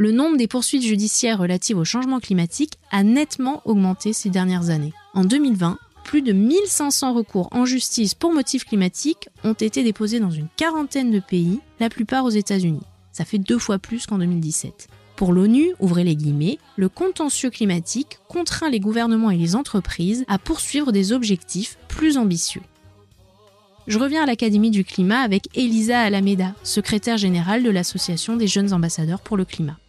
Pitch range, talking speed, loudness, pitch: 185-250 Hz, 170 wpm, -20 LUFS, 210 Hz